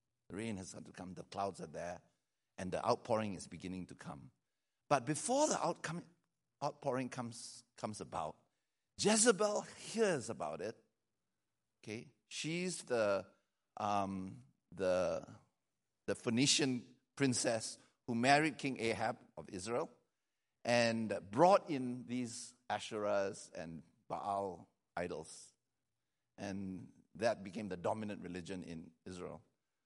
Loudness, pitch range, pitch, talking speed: -38 LUFS, 100-145 Hz, 120 Hz, 115 wpm